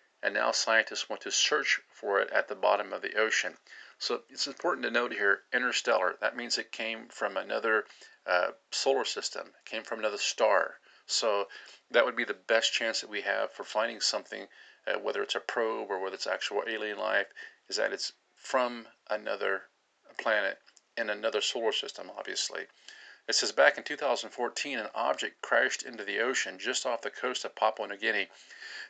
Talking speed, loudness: 185 wpm, -30 LUFS